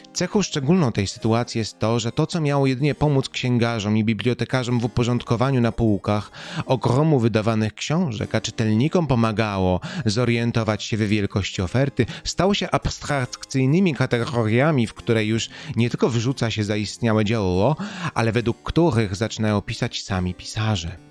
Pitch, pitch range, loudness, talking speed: 115 Hz, 110-135 Hz, -22 LUFS, 140 wpm